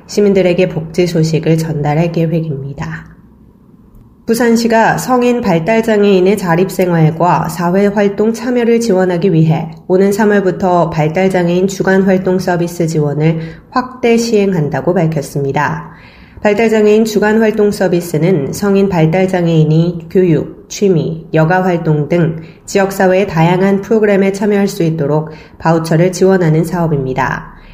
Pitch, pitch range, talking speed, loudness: 180 Hz, 160-200 Hz, 310 characters per minute, -12 LUFS